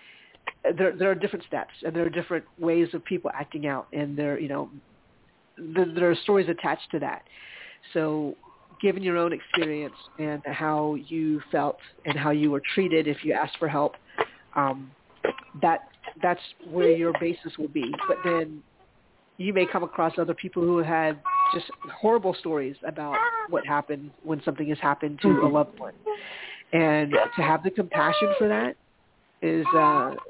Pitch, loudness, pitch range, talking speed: 165 Hz, -26 LUFS, 150-185 Hz, 170 wpm